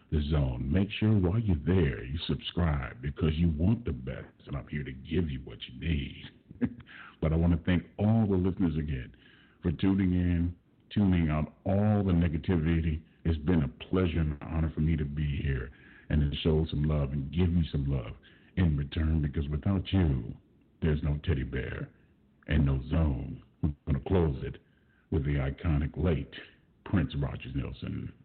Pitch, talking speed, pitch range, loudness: 80 Hz, 180 wpm, 70-90 Hz, -30 LUFS